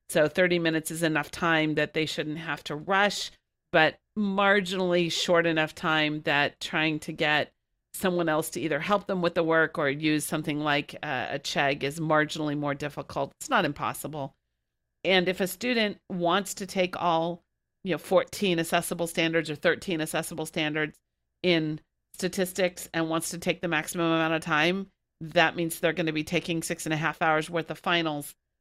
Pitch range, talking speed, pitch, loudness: 155-180 Hz, 180 wpm, 165 Hz, -27 LUFS